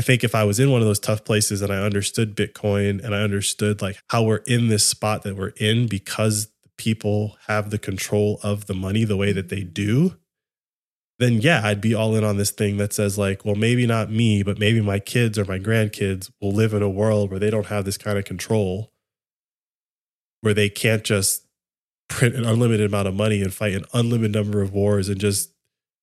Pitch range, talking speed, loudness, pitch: 100-110 Hz, 220 wpm, -21 LUFS, 105 Hz